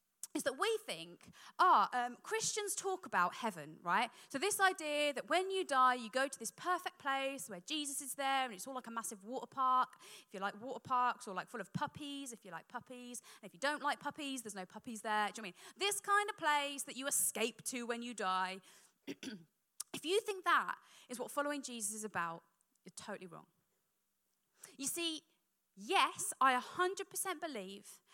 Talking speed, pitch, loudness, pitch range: 205 wpm, 260 Hz, -37 LUFS, 220-310 Hz